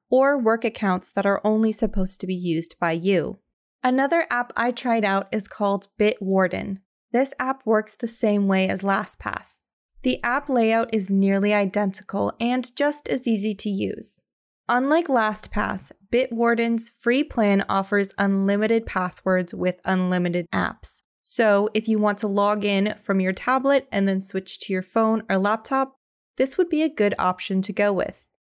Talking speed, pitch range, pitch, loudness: 165 wpm, 195-235 Hz, 210 Hz, -23 LUFS